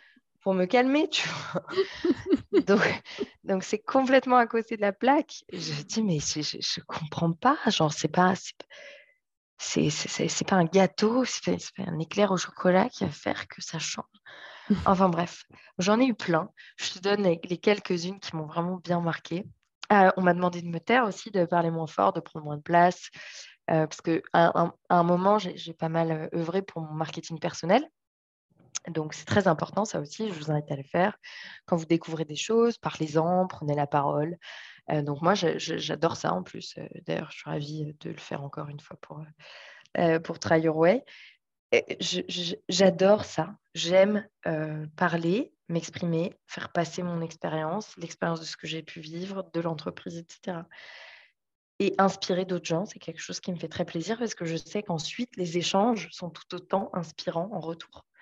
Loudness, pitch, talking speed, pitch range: -27 LUFS, 175 Hz, 200 wpm, 165-200 Hz